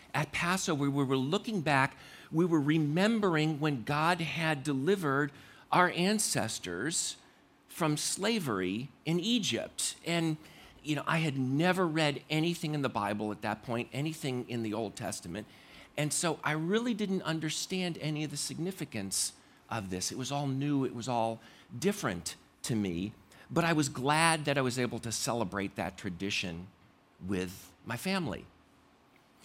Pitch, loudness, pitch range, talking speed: 145 Hz, -32 LUFS, 115-165 Hz, 155 wpm